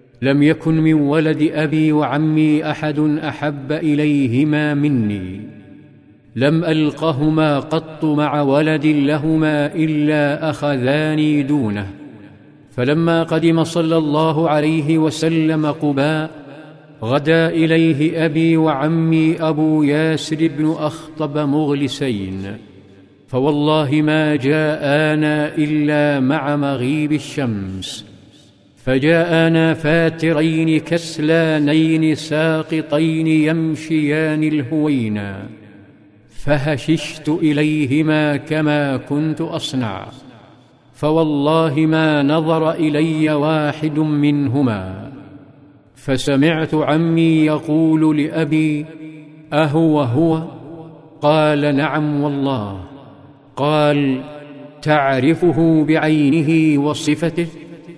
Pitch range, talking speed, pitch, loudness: 145-160 Hz, 75 wpm, 150 Hz, -16 LUFS